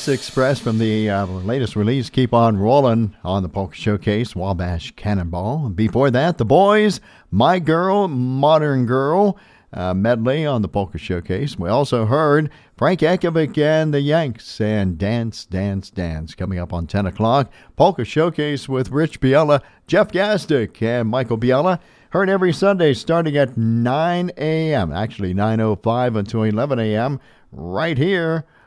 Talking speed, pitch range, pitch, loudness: 145 wpm, 105-150 Hz, 125 Hz, -19 LUFS